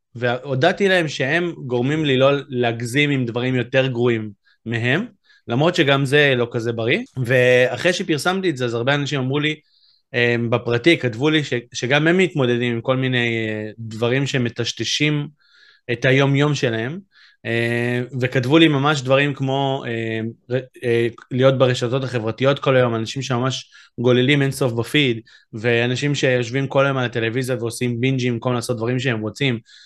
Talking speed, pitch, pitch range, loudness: 140 wpm, 130 Hz, 120-140 Hz, -19 LUFS